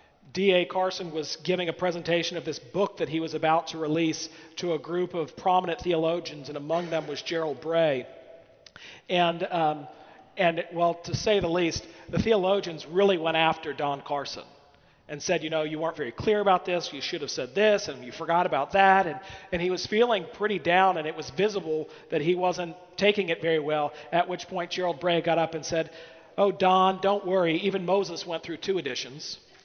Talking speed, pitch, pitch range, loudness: 200 wpm, 170 Hz, 160-185 Hz, -27 LUFS